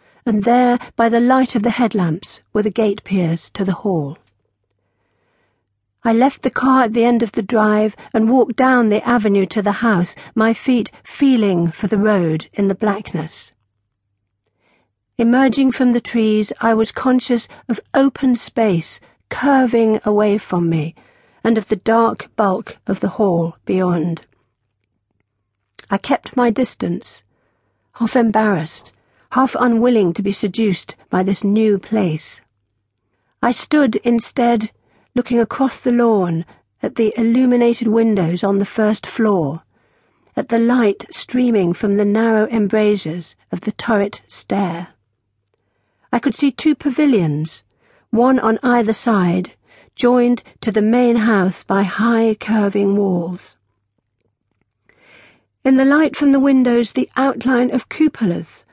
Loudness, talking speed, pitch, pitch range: -16 LUFS, 140 wpm, 215 Hz, 170-240 Hz